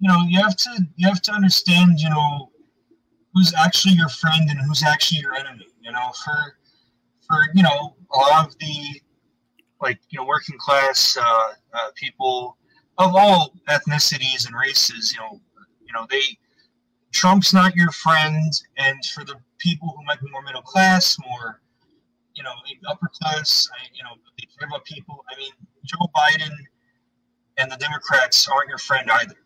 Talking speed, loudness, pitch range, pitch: 175 wpm, -18 LUFS, 135-185 Hz, 155 Hz